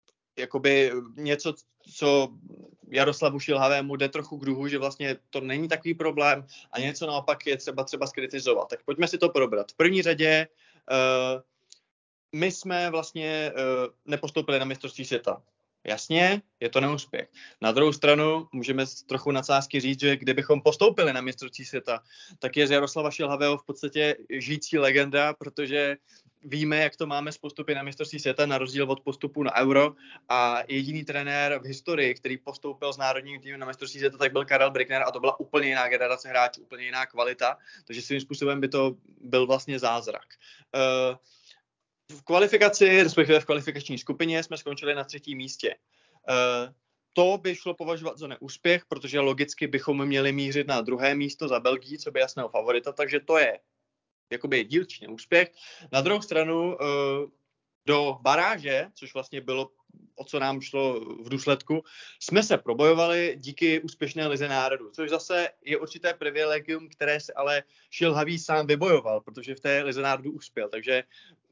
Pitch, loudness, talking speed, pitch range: 140 Hz, -26 LUFS, 160 wpm, 135-155 Hz